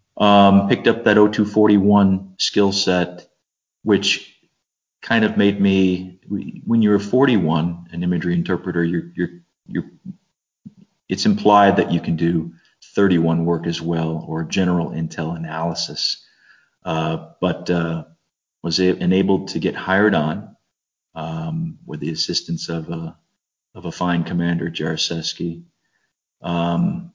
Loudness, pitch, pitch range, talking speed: -19 LUFS, 90 Hz, 85-100 Hz, 125 wpm